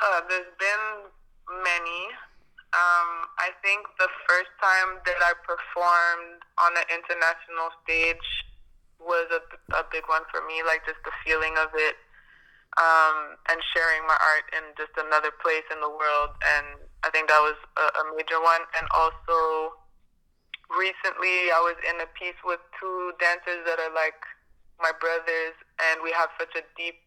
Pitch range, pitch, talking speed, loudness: 160-175 Hz, 165 Hz, 160 wpm, -25 LUFS